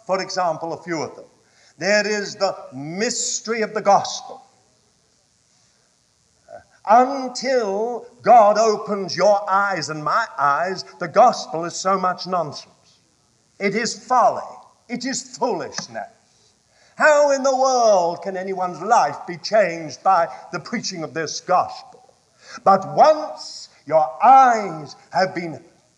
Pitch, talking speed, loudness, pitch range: 200 Hz, 125 wpm, -19 LUFS, 175-245 Hz